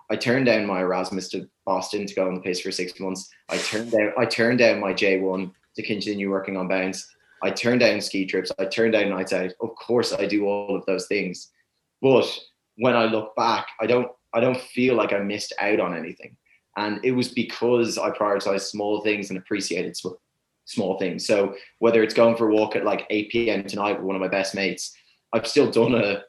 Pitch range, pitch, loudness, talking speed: 95-115 Hz, 105 Hz, -23 LUFS, 220 wpm